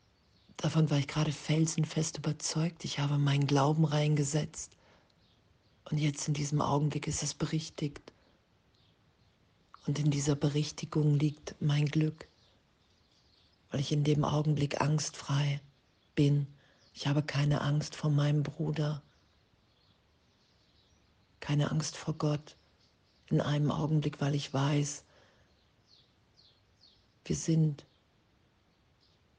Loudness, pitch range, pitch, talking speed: -32 LUFS, 125-150 Hz, 145 Hz, 105 wpm